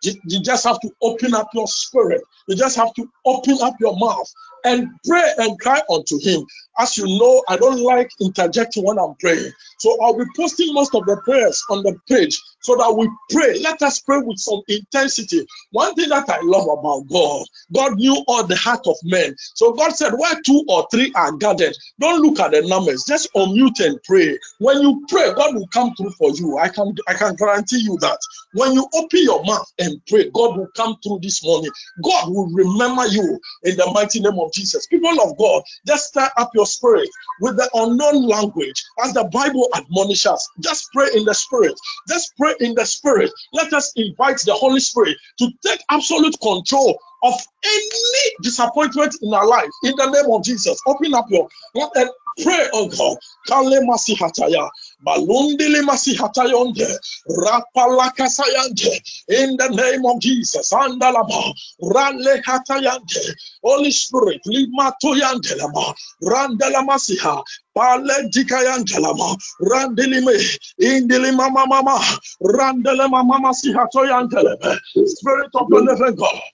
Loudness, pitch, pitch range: -17 LUFS, 260 Hz, 225-300 Hz